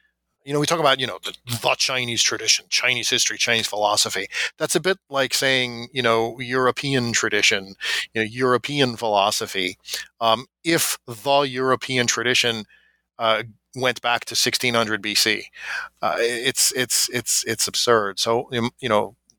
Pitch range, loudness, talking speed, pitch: 115-130 Hz, -21 LUFS, 150 wpm, 120 Hz